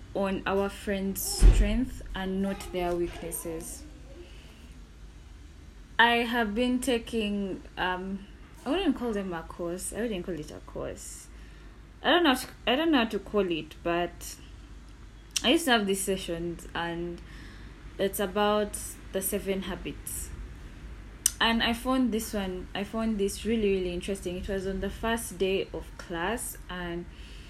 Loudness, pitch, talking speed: -29 LUFS, 190 Hz, 155 wpm